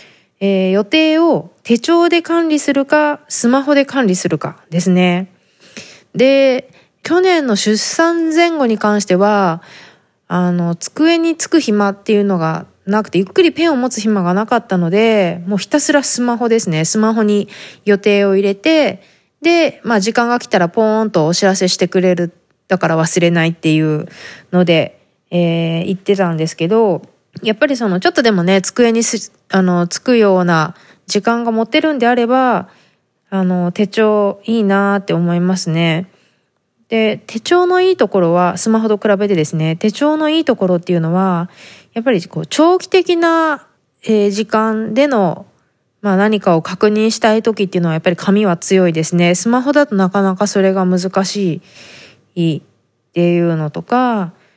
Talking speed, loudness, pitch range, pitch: 310 characters per minute, -14 LUFS, 180-240 Hz, 205 Hz